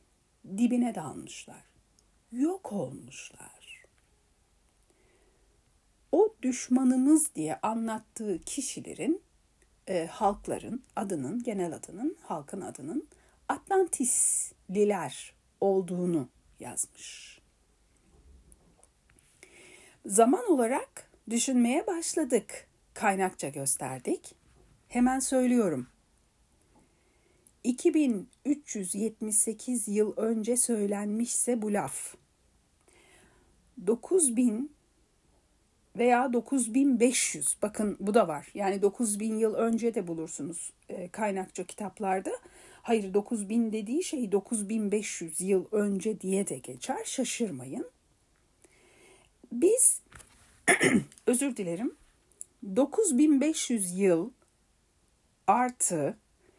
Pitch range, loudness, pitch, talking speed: 200-265 Hz, -29 LUFS, 230 Hz, 70 wpm